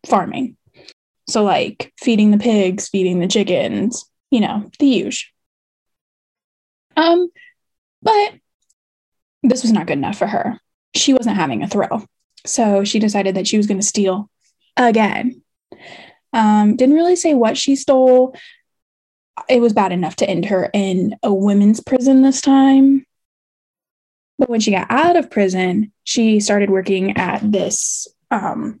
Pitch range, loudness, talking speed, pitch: 200-270 Hz, -16 LUFS, 145 wpm, 225 Hz